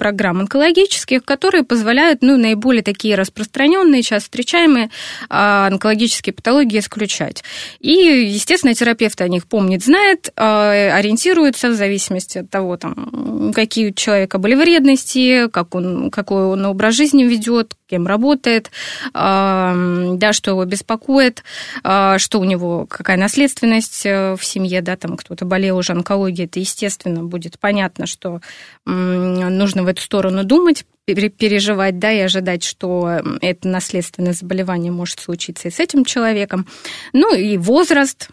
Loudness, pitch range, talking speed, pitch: -15 LUFS, 185-245 Hz, 130 wpm, 205 Hz